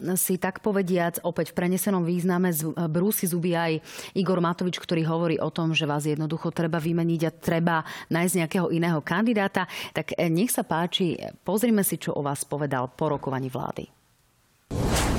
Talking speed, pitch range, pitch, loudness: 160 wpm, 160-185 Hz, 170 Hz, -26 LUFS